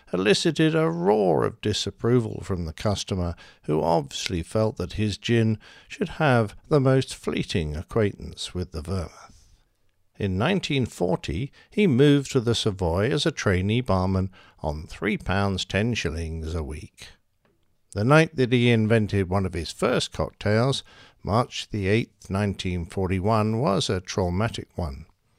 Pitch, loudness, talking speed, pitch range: 105 Hz, -25 LUFS, 140 wpm, 90-120 Hz